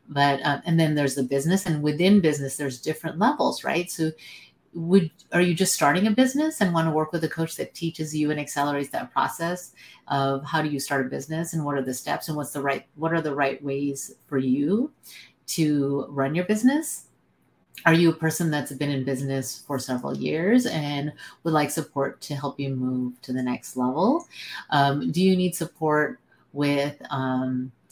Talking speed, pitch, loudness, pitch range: 200 wpm, 150 Hz, -25 LUFS, 140-165 Hz